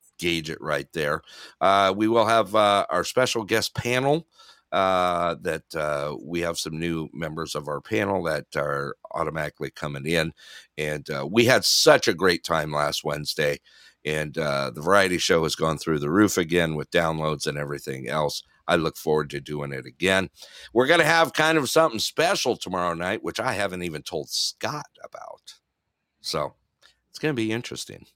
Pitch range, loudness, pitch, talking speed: 75-110 Hz, -24 LUFS, 85 Hz, 180 wpm